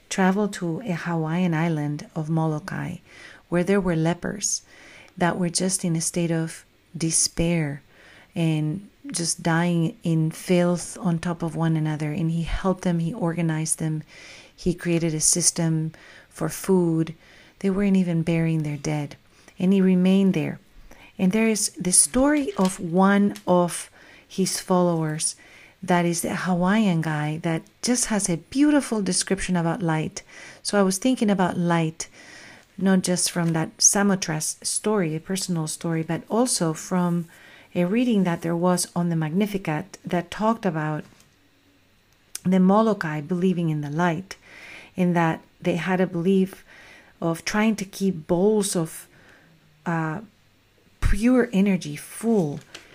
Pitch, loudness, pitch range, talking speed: 175 Hz, -23 LUFS, 160-190 Hz, 145 wpm